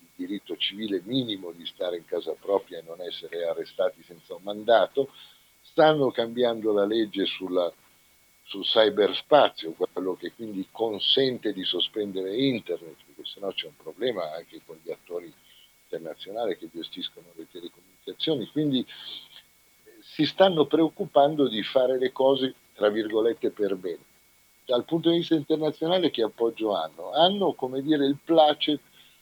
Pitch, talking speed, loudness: 155 Hz, 140 wpm, -26 LUFS